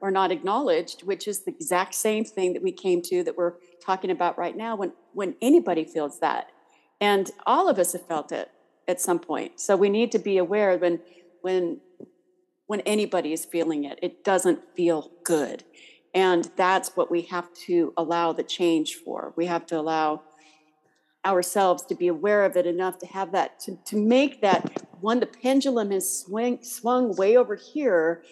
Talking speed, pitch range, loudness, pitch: 185 wpm, 175-225 Hz, -25 LUFS, 185 Hz